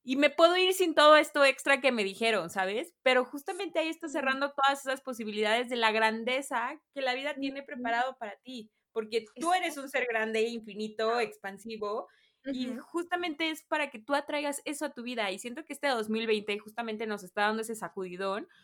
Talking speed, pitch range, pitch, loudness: 195 wpm, 220-290 Hz, 255 Hz, -30 LUFS